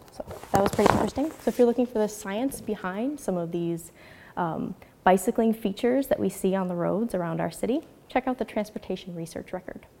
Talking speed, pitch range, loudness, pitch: 200 wpm, 185-240 Hz, -27 LUFS, 215 Hz